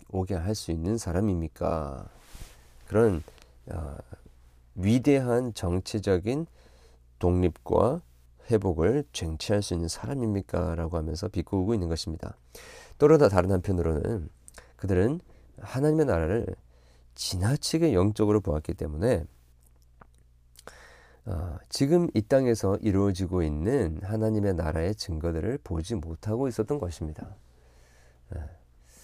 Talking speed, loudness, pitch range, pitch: 255 characters per minute, -27 LUFS, 75-110 Hz, 90 Hz